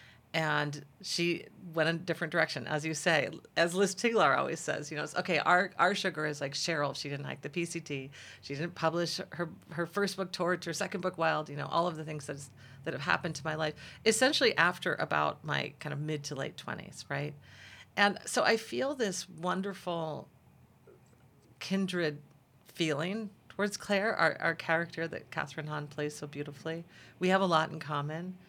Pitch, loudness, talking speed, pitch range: 160 Hz, -32 LUFS, 190 wpm, 145-180 Hz